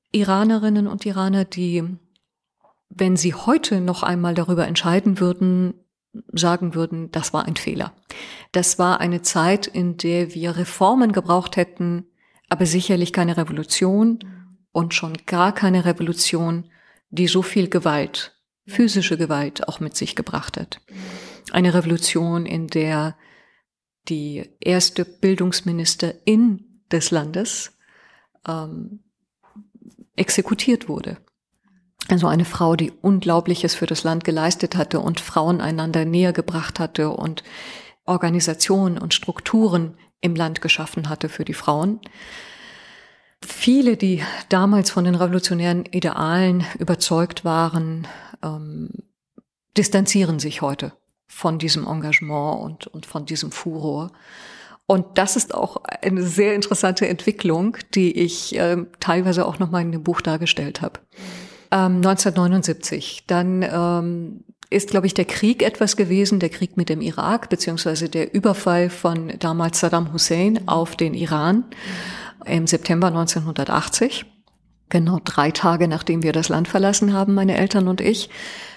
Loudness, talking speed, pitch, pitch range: -20 LUFS, 130 wpm, 180 Hz, 165-195 Hz